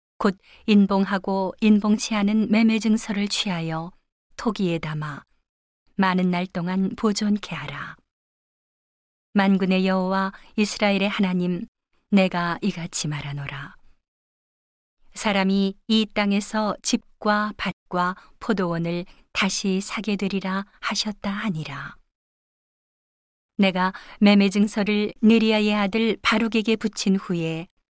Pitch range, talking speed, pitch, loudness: 180-215 Hz, 225 characters per minute, 200 Hz, -23 LUFS